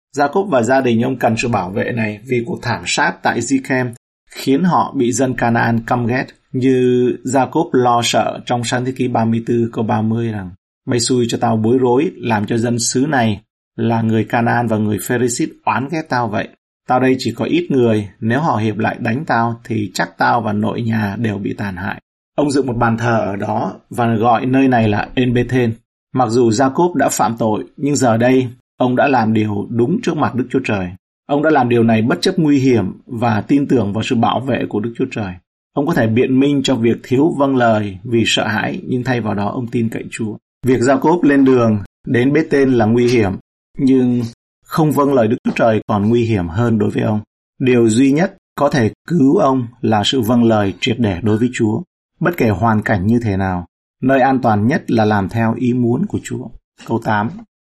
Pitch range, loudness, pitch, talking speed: 110-130 Hz, -16 LUFS, 120 Hz, 220 wpm